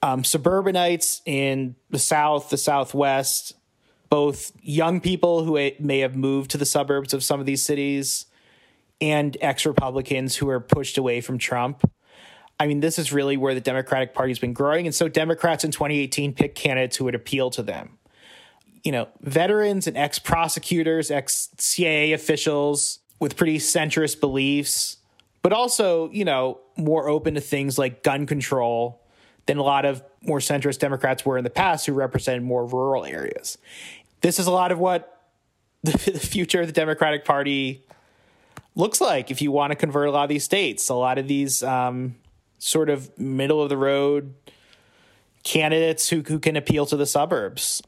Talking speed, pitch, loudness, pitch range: 175 wpm, 145 Hz, -22 LUFS, 135-160 Hz